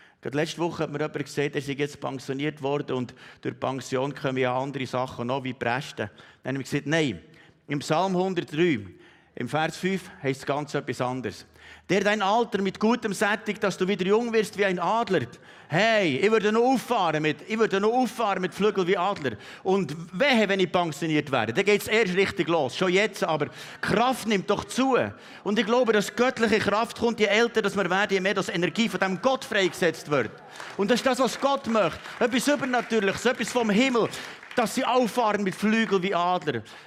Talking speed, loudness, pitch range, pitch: 195 wpm, -25 LUFS, 150-220 Hz, 190 Hz